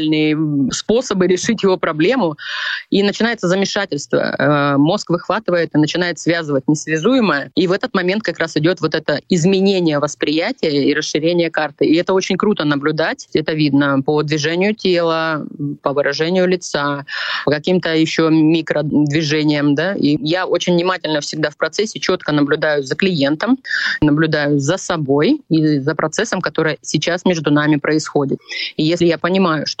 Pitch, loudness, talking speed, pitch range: 160 Hz, -16 LUFS, 145 wpm, 150-185 Hz